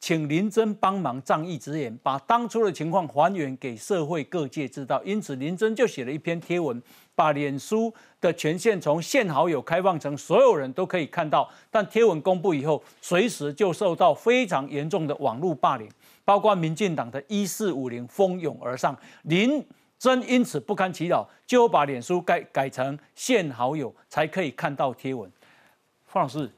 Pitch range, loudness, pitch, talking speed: 145-205 Hz, -25 LUFS, 170 Hz, 260 characters per minute